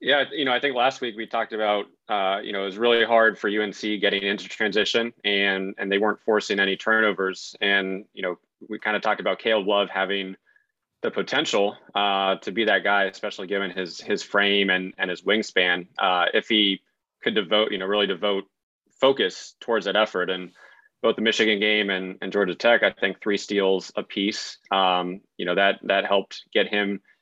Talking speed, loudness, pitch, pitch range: 200 wpm, -23 LUFS, 100 Hz, 95-110 Hz